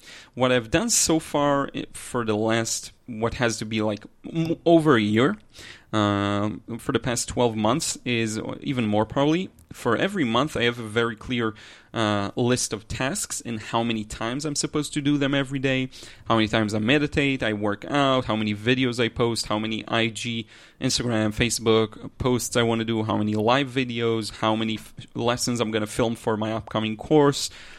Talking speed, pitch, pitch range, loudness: 190 wpm, 115 Hz, 110-130 Hz, -24 LUFS